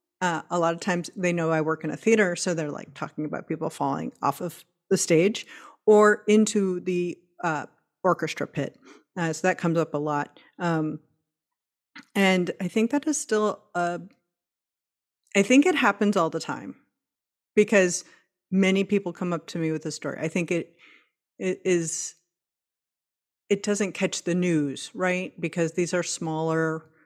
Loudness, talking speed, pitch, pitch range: -25 LUFS, 170 wpm, 175 Hz, 165-200 Hz